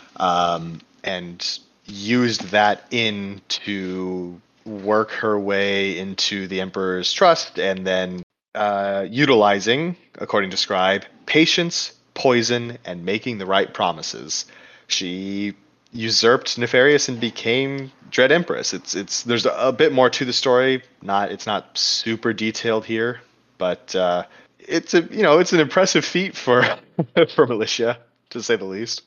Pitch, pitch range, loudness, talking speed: 110 Hz, 100-130 Hz, -20 LUFS, 140 wpm